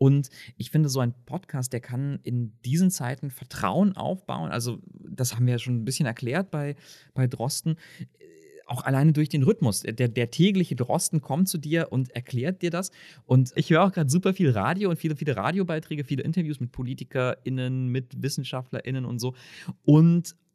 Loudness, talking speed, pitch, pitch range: -26 LUFS, 180 wpm, 140 Hz, 125-165 Hz